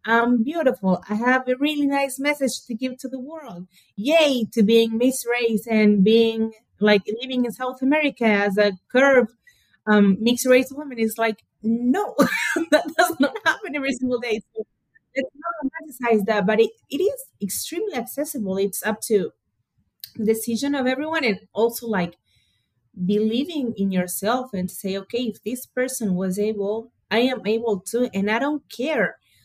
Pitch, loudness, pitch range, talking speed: 235 Hz, -22 LUFS, 210-265 Hz, 170 wpm